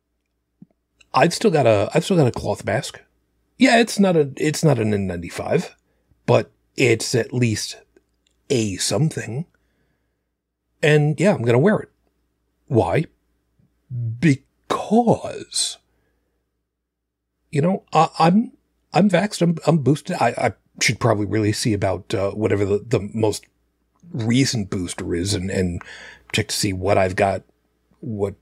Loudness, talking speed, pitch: -20 LUFS, 135 wpm, 105 Hz